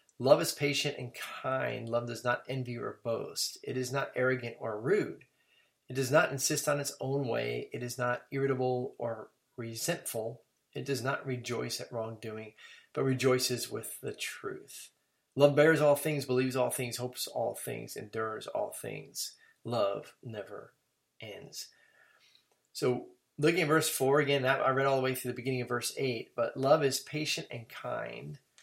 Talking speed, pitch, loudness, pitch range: 170 wpm, 130 Hz, -32 LUFS, 120-140 Hz